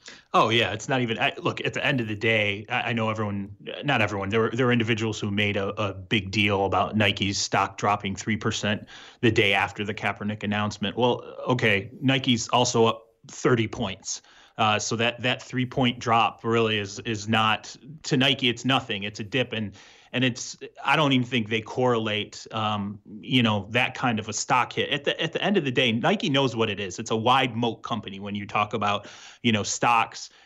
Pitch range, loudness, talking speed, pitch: 105-125 Hz, -25 LUFS, 215 wpm, 115 Hz